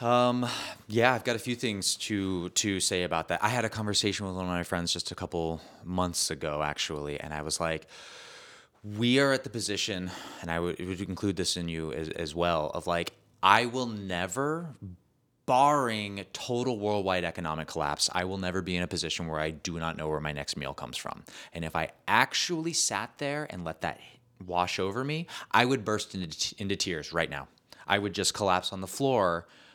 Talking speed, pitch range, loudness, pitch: 210 wpm, 85-115 Hz, -30 LUFS, 95 Hz